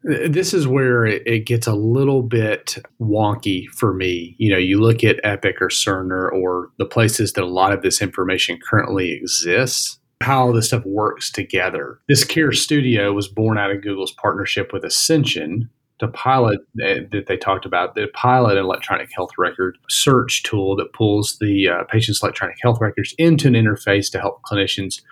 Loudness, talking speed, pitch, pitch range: -18 LUFS, 180 wpm, 110 Hz, 100-125 Hz